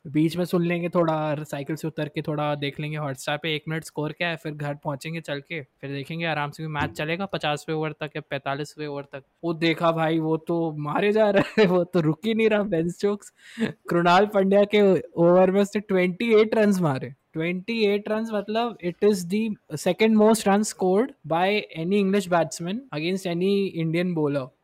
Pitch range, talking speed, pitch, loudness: 155-200 Hz, 190 wpm, 170 Hz, -24 LUFS